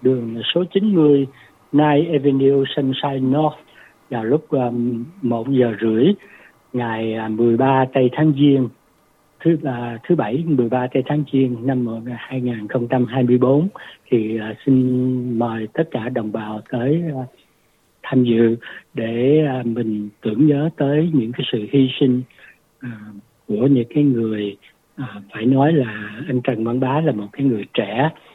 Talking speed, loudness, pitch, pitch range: 150 wpm, -19 LUFS, 130 Hz, 115-145 Hz